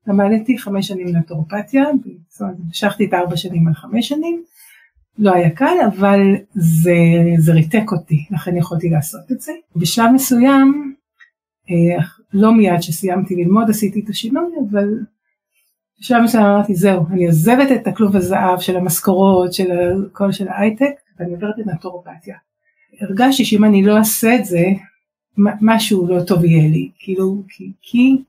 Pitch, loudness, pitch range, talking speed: 200 Hz, -15 LUFS, 180-230 Hz, 145 wpm